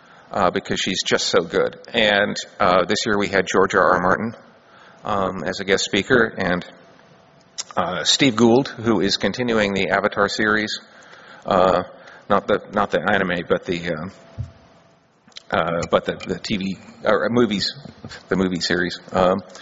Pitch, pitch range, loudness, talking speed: 100 Hz, 95-110 Hz, -20 LUFS, 145 wpm